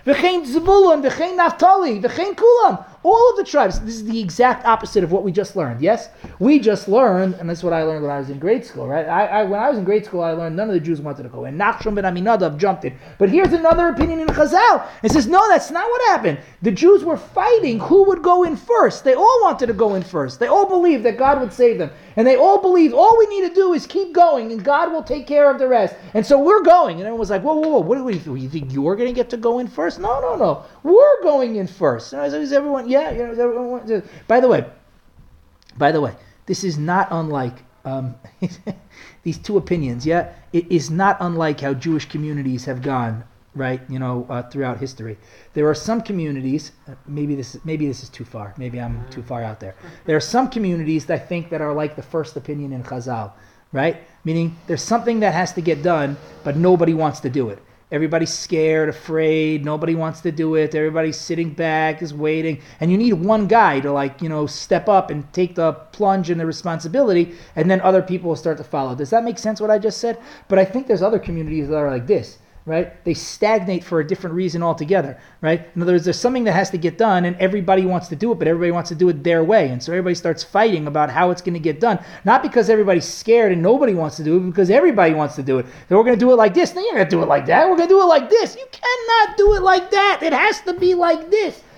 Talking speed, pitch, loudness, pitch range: 255 wpm, 180 Hz, -17 LUFS, 155-240 Hz